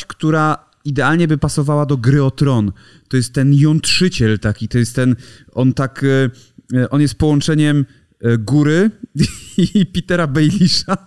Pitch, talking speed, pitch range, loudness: 145 Hz, 135 wpm, 130-160 Hz, -15 LUFS